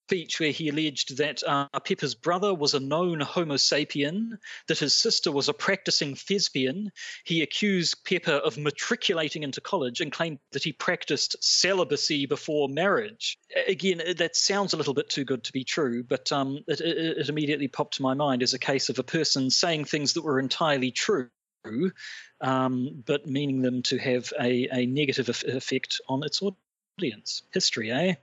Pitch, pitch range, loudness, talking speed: 150 Hz, 135-175 Hz, -26 LUFS, 175 wpm